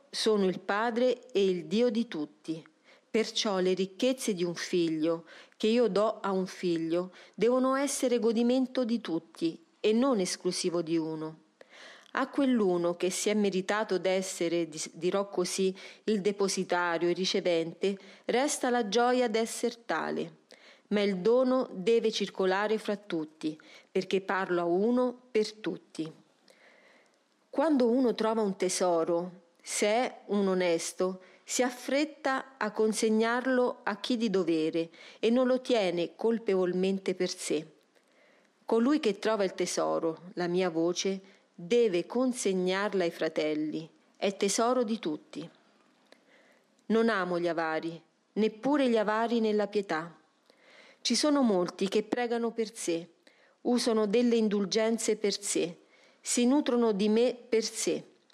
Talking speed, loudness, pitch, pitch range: 135 wpm, -30 LUFS, 205 Hz, 180-235 Hz